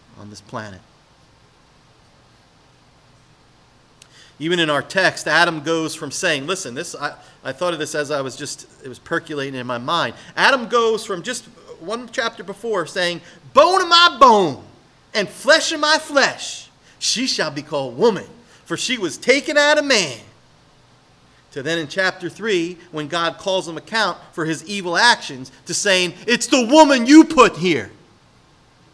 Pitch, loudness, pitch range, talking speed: 180 Hz, -17 LUFS, 155-240 Hz, 165 wpm